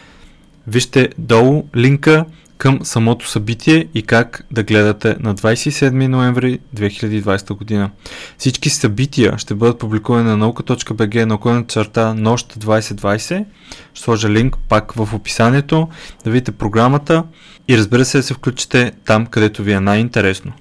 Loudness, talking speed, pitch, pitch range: -15 LUFS, 135 wpm, 115 Hz, 110-135 Hz